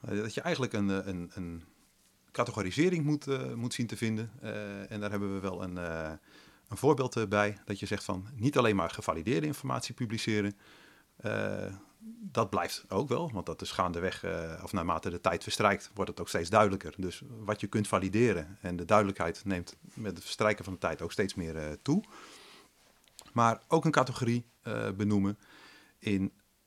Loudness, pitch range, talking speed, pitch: -32 LUFS, 95-115 Hz, 180 wpm, 105 Hz